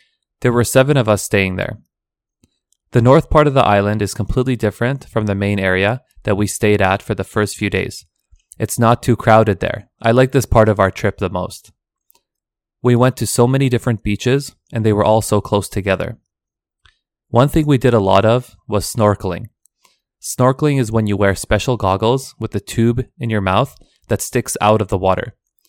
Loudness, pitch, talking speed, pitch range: -16 LUFS, 110 Hz, 200 wpm, 100-125 Hz